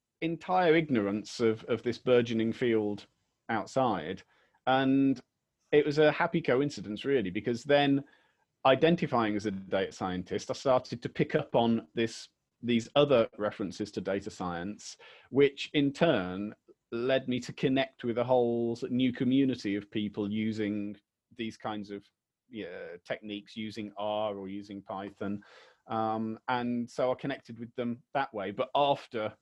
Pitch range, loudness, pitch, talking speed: 105-135 Hz, -30 LUFS, 120 Hz, 145 wpm